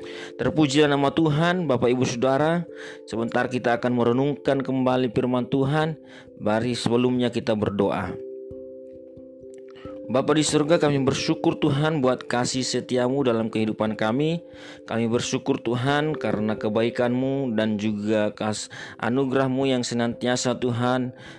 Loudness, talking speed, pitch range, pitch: -23 LUFS, 115 wpm, 110-135 Hz, 125 Hz